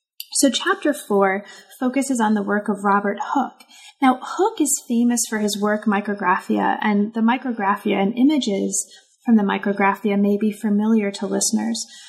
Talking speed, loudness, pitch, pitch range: 155 wpm, -20 LUFS, 215 Hz, 200-260 Hz